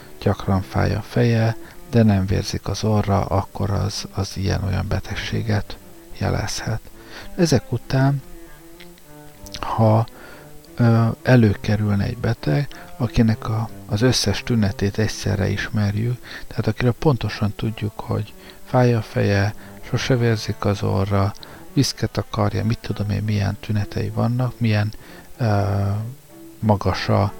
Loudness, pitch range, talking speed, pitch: -21 LUFS, 100-120 Hz, 115 wpm, 110 Hz